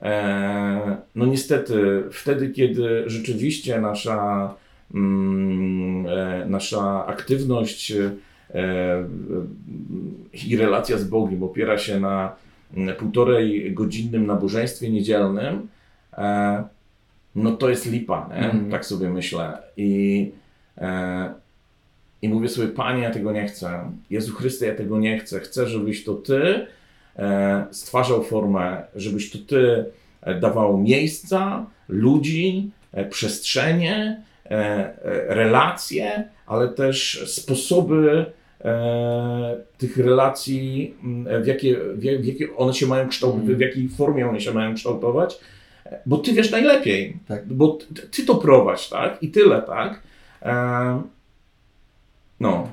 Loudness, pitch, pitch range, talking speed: -22 LUFS, 110 Hz, 100-130 Hz, 110 wpm